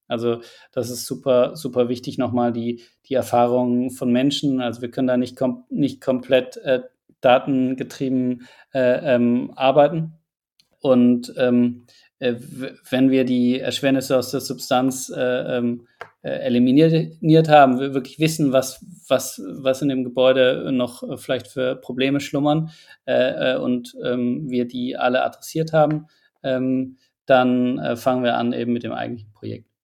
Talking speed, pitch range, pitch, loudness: 150 wpm, 125-135 Hz, 130 Hz, -20 LUFS